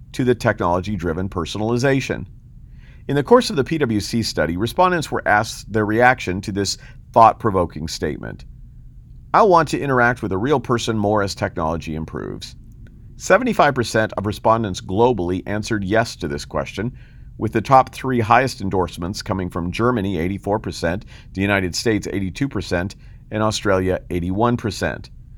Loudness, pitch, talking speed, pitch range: -19 LUFS, 105 Hz, 140 wpm, 95-120 Hz